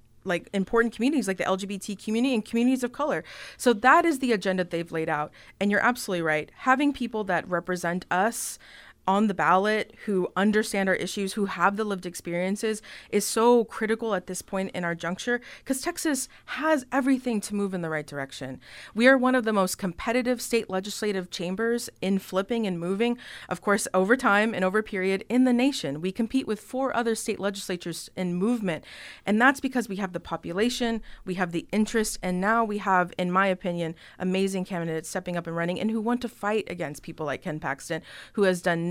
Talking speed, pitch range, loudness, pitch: 200 wpm, 180-230 Hz, -26 LUFS, 200 Hz